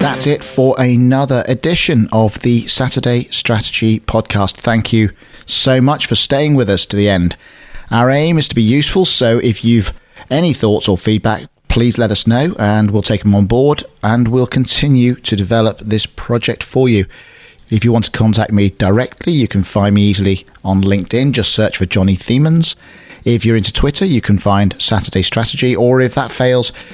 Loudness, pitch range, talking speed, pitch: -13 LUFS, 105-130 Hz, 190 wpm, 115 Hz